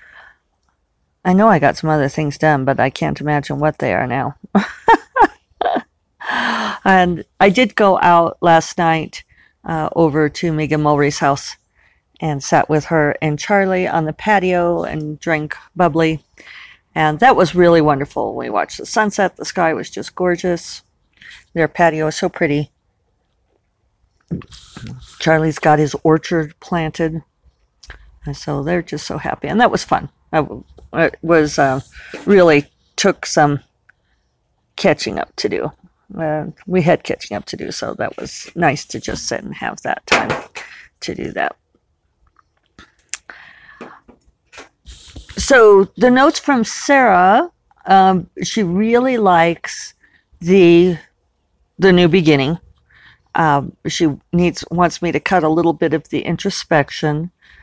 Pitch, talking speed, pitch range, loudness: 165 Hz, 140 wpm, 150-185 Hz, -16 LUFS